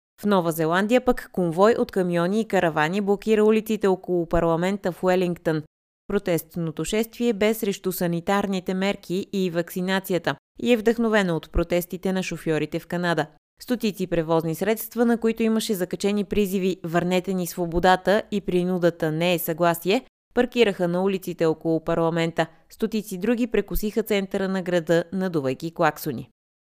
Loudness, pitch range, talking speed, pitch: -24 LUFS, 170-205 Hz, 135 wpm, 185 Hz